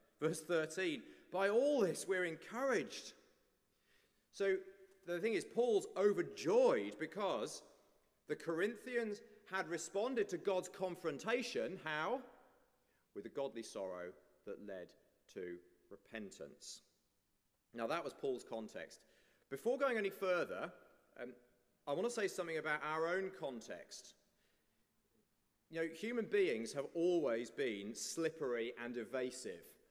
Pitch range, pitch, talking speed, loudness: 155-245 Hz, 190 Hz, 120 wpm, -40 LUFS